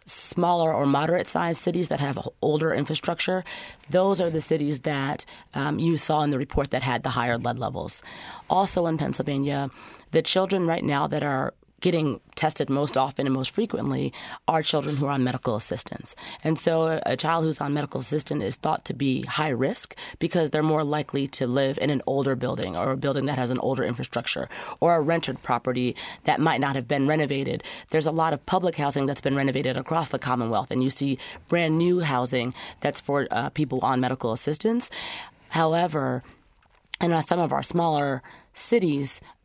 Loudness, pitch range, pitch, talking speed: -25 LUFS, 135-165 Hz, 145 Hz, 190 wpm